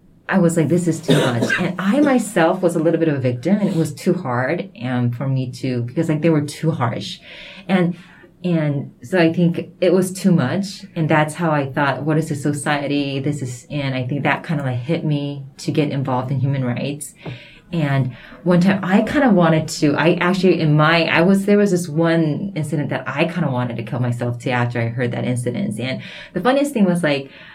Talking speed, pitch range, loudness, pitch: 225 wpm, 135-175 Hz, -19 LUFS, 155 Hz